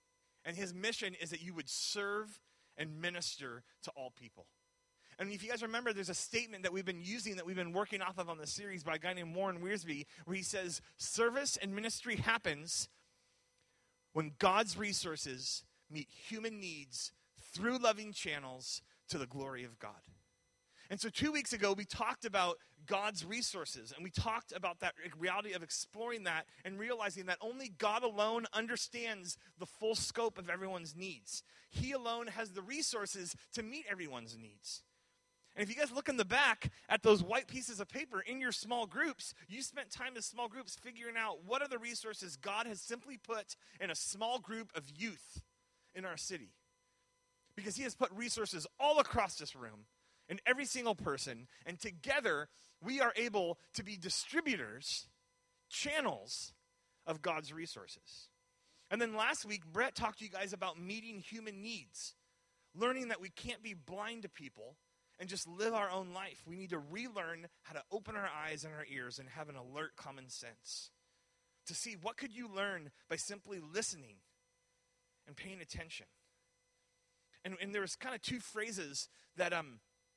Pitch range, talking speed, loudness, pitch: 155-225 Hz, 175 wpm, -40 LUFS, 190 Hz